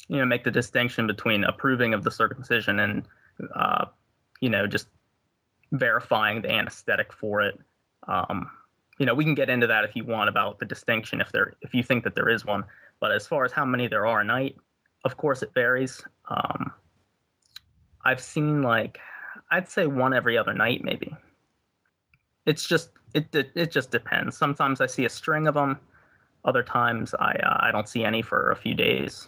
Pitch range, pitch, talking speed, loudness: 120-150 Hz, 130 Hz, 195 wpm, -25 LUFS